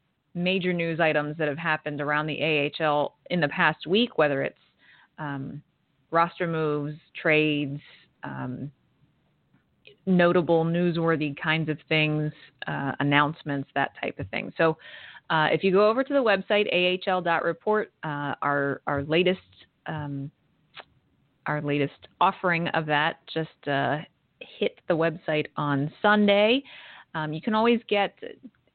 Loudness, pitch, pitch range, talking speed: -25 LUFS, 155 Hz, 145-180 Hz, 135 wpm